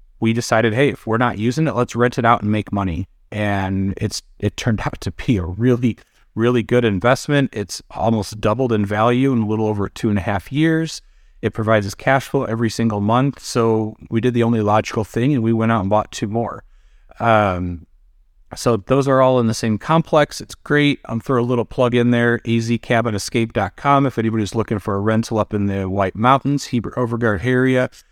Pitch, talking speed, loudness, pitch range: 115 Hz, 205 wpm, -18 LUFS, 105-125 Hz